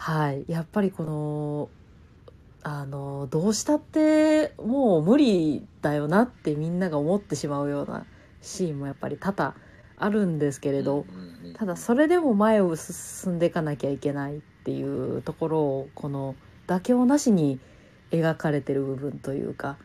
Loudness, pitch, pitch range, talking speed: -26 LUFS, 155 Hz, 140-195 Hz, 310 characters per minute